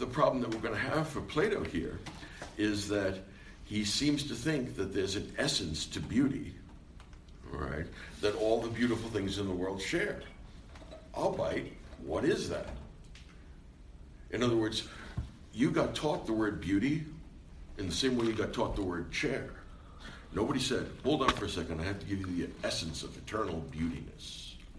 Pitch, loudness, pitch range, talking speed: 95 Hz, -34 LUFS, 80-110 Hz, 175 wpm